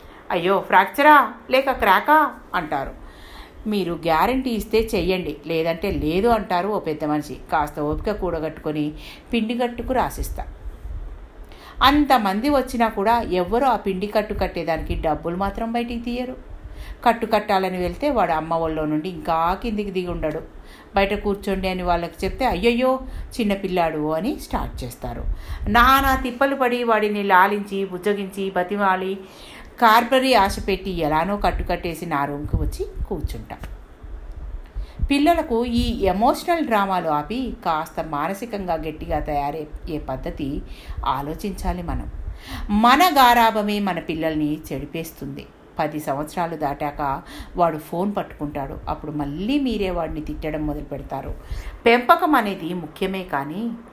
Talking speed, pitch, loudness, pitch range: 115 wpm, 190 Hz, -21 LUFS, 160-230 Hz